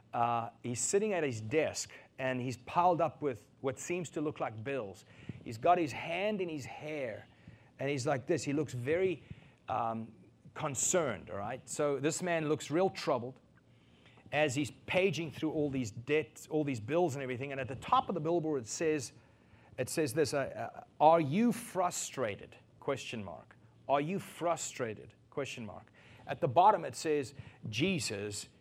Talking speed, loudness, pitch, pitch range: 170 wpm, -34 LUFS, 145 Hz, 125-165 Hz